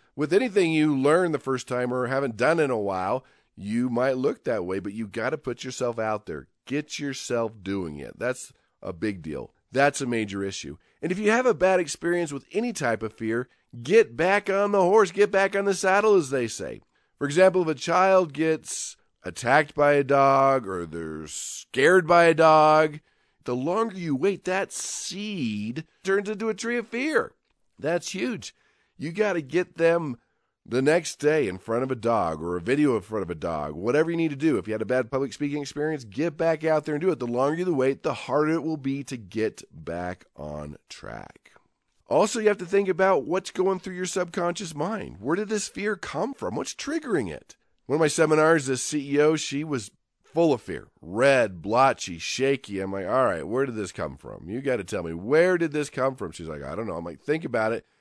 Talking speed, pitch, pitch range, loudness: 220 wpm, 150 Hz, 125-185 Hz, -25 LUFS